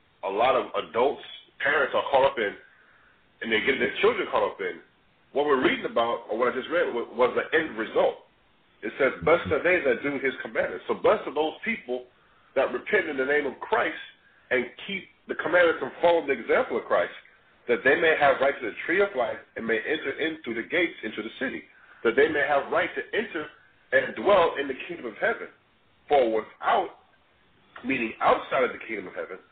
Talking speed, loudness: 210 wpm, -26 LUFS